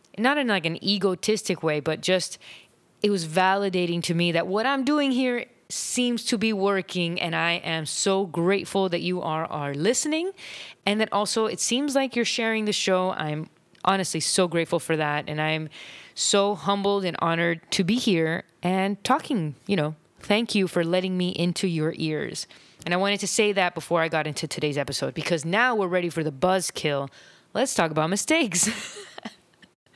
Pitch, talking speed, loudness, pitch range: 185 Hz, 185 wpm, -24 LUFS, 165-205 Hz